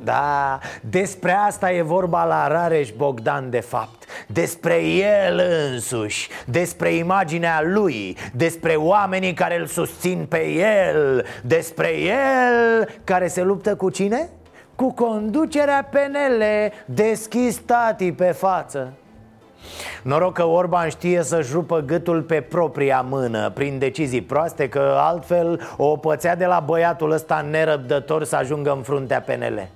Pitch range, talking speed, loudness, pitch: 145-190 Hz, 130 wpm, -20 LUFS, 170 Hz